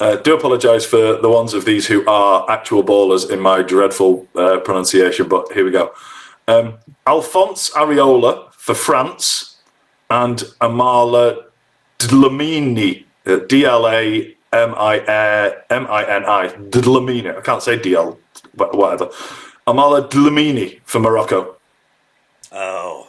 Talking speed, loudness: 110 wpm, -14 LUFS